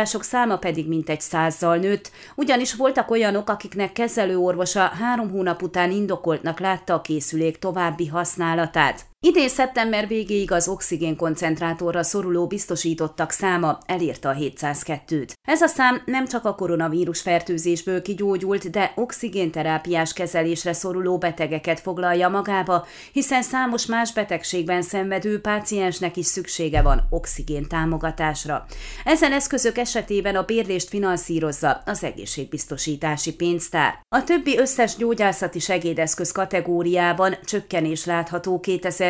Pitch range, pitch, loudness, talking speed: 165-210 Hz, 180 Hz, -22 LUFS, 115 wpm